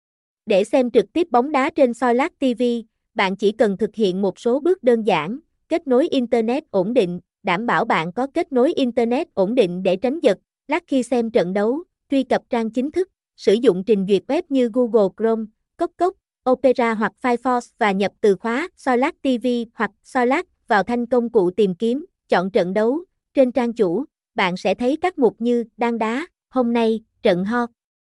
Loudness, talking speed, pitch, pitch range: -20 LUFS, 195 wpm, 240 Hz, 215-265 Hz